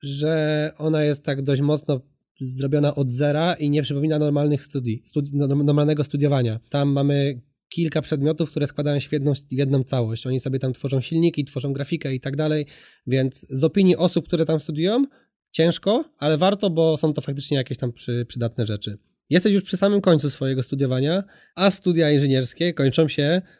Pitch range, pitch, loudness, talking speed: 135-160 Hz, 145 Hz, -22 LUFS, 180 wpm